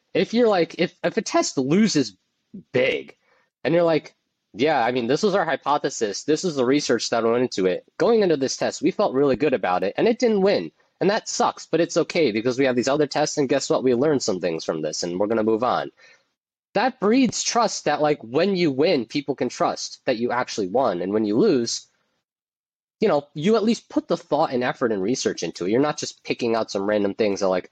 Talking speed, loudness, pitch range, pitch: 240 wpm, -22 LUFS, 125-195 Hz, 150 Hz